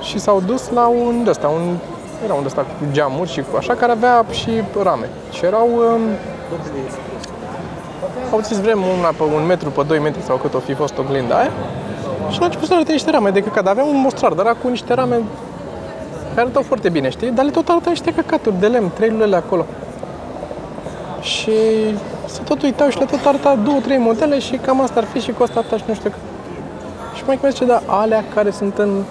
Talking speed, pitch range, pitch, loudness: 215 wpm, 200-260 Hz, 230 Hz, -17 LUFS